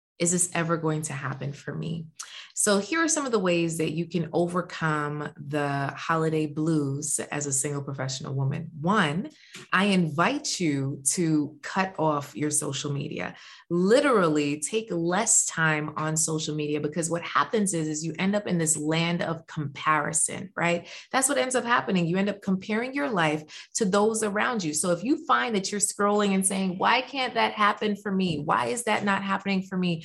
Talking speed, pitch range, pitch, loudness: 190 wpm, 155-205 Hz, 170 Hz, -26 LUFS